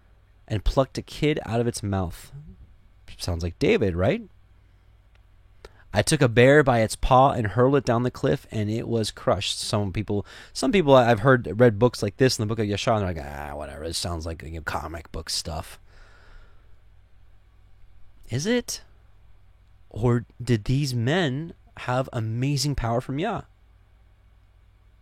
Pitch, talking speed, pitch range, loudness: 100 Hz, 160 wpm, 95-125 Hz, -24 LUFS